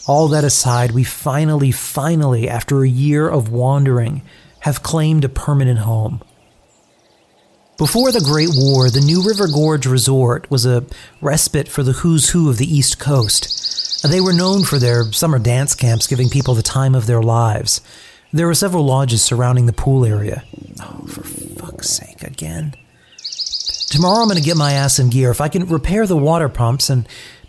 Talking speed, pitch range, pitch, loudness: 175 wpm, 125-155 Hz, 135 Hz, -15 LUFS